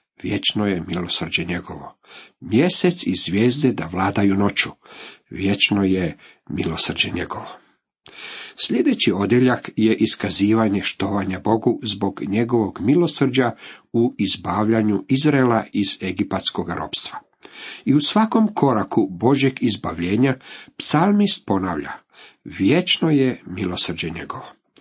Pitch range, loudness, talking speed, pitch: 100-135 Hz, -20 LUFS, 100 wpm, 110 Hz